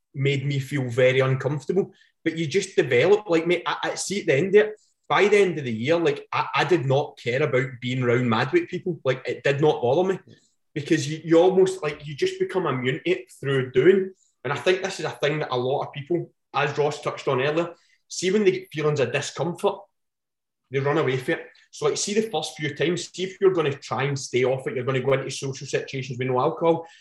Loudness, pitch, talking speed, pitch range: -24 LUFS, 155 Hz, 250 wpm, 135-185 Hz